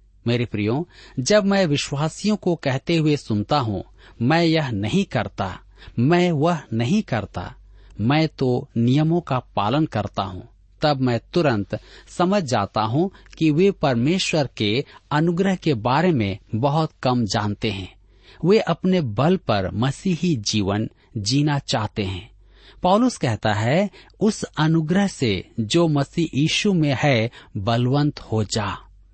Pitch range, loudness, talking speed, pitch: 105-165 Hz, -21 LUFS, 135 wpm, 130 Hz